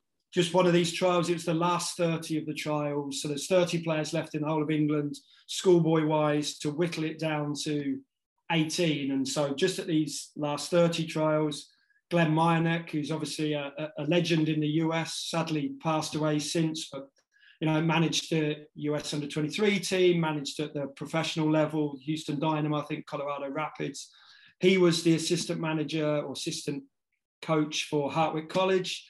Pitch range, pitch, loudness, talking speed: 150-170 Hz, 155 Hz, -29 LUFS, 175 wpm